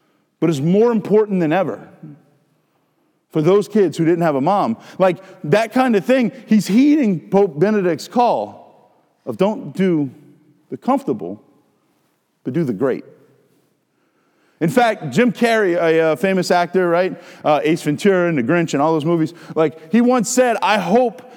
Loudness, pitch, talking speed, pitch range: -17 LUFS, 185 Hz, 165 wpm, 160-225 Hz